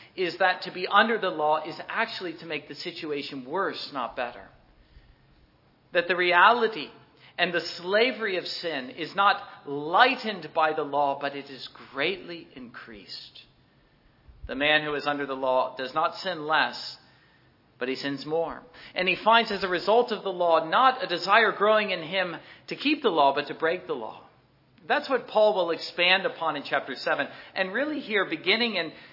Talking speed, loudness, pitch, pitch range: 180 wpm, -25 LUFS, 175 Hz, 145-200 Hz